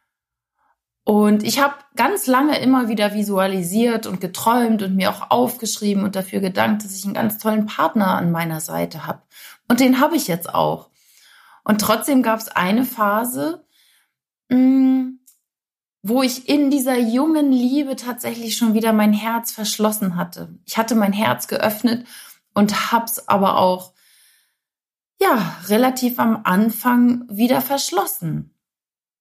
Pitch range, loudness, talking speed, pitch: 205-255 Hz, -19 LUFS, 140 wpm, 225 Hz